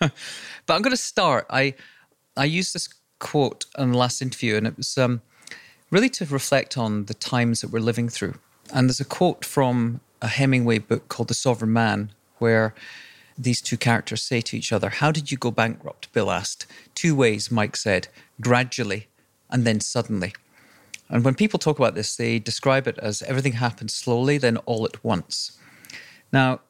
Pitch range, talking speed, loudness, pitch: 115-135 Hz, 180 wpm, -23 LUFS, 120 Hz